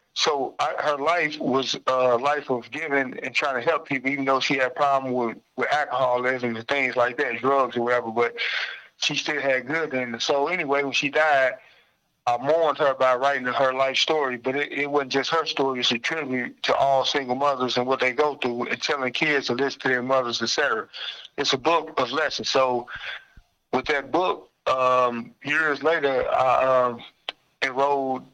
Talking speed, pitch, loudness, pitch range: 195 wpm, 135 Hz, -23 LUFS, 125-140 Hz